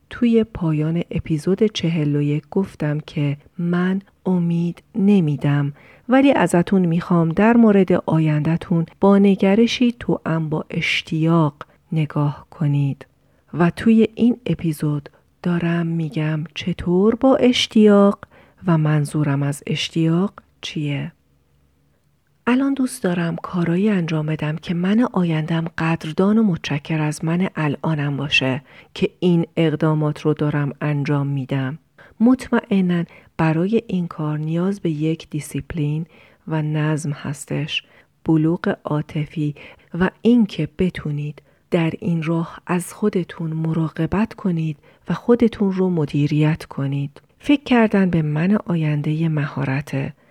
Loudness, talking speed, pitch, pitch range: -20 LUFS, 110 wpm, 165 Hz, 150-185 Hz